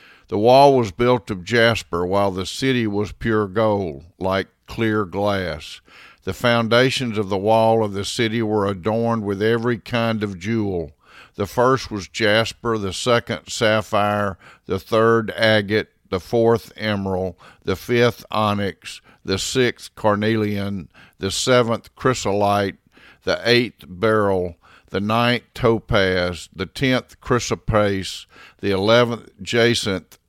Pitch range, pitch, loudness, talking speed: 95-115 Hz, 105 Hz, -20 LUFS, 125 wpm